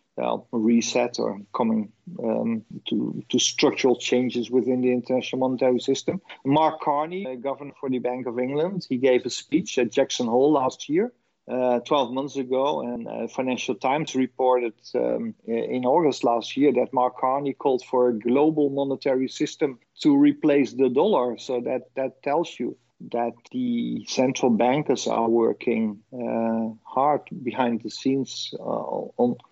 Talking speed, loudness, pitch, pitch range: 155 wpm, -24 LUFS, 130 Hz, 120-145 Hz